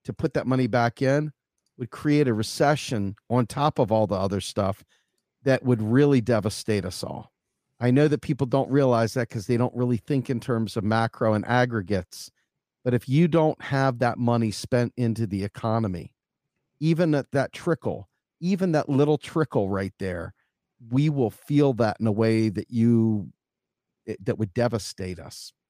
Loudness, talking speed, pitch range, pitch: -24 LUFS, 175 wpm, 110-140 Hz, 120 Hz